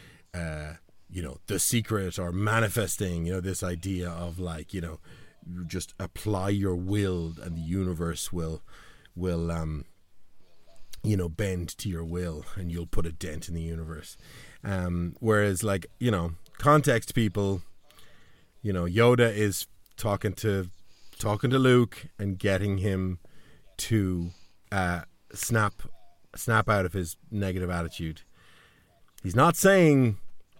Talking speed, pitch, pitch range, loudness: 135 wpm, 95 Hz, 85-105 Hz, -28 LUFS